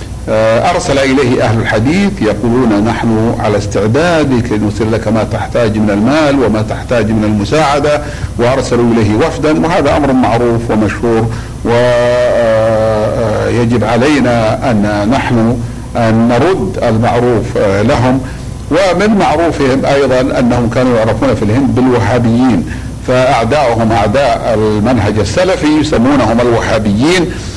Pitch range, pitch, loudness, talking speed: 110-125 Hz, 115 Hz, -11 LUFS, 105 wpm